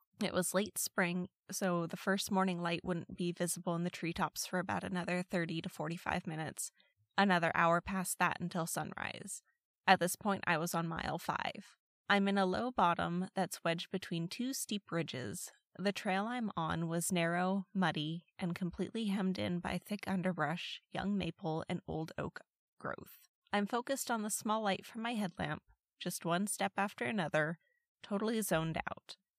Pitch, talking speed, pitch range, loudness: 180 Hz, 170 wpm, 170-200 Hz, -37 LUFS